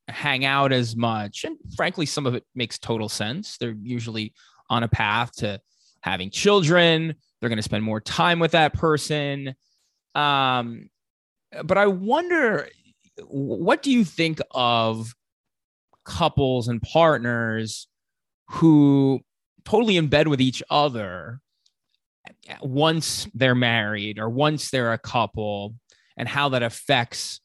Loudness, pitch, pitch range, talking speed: -22 LUFS, 125 Hz, 115-155 Hz, 130 wpm